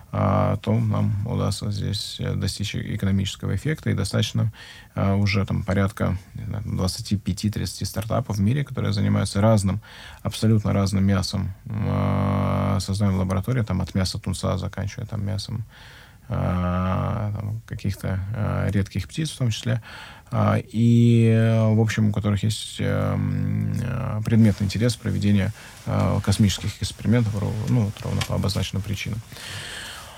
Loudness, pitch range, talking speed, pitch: -24 LUFS, 100-115 Hz, 105 wpm, 105 Hz